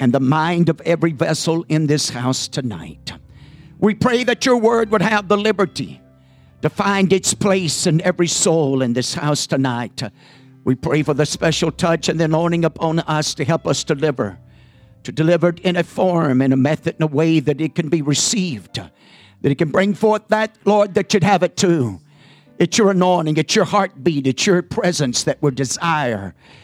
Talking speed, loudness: 195 wpm, -17 LUFS